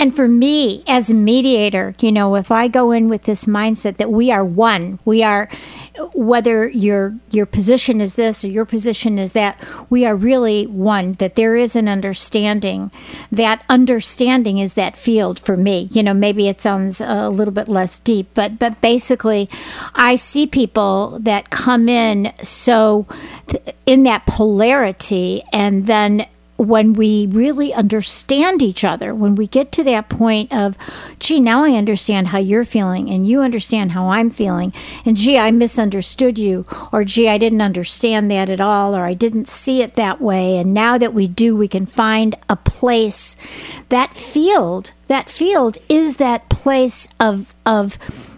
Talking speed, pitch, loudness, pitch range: 170 wpm, 220 Hz, -15 LUFS, 205-240 Hz